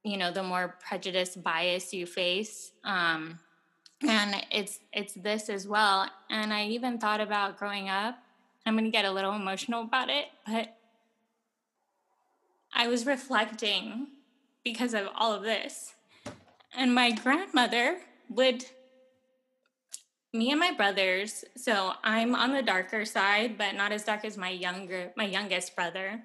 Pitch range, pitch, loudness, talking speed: 195-245 Hz, 215 Hz, -29 LUFS, 145 wpm